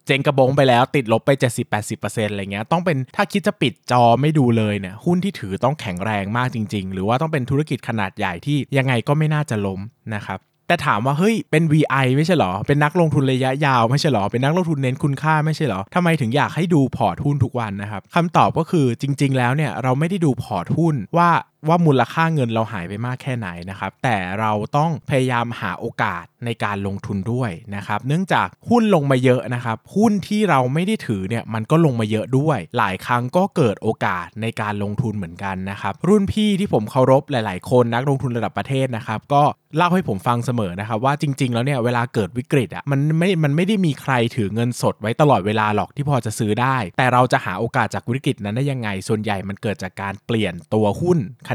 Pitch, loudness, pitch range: 125 Hz, -20 LUFS, 110-150 Hz